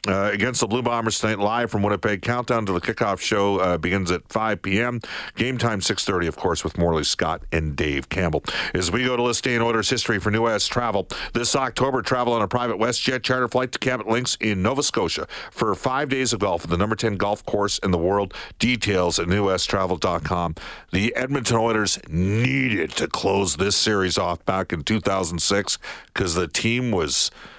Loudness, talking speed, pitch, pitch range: -22 LUFS, 195 wpm, 105 Hz, 95-120 Hz